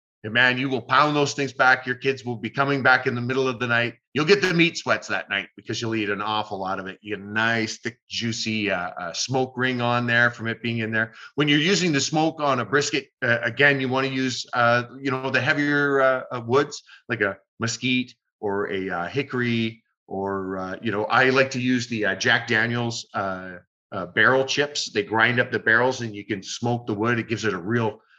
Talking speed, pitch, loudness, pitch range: 240 wpm, 120 Hz, -23 LUFS, 110-130 Hz